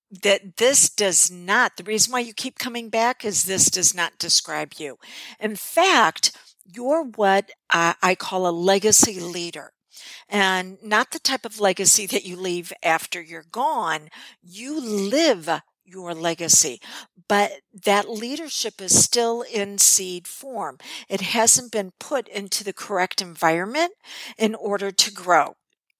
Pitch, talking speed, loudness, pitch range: 200 Hz, 145 wpm, -20 LUFS, 185-235 Hz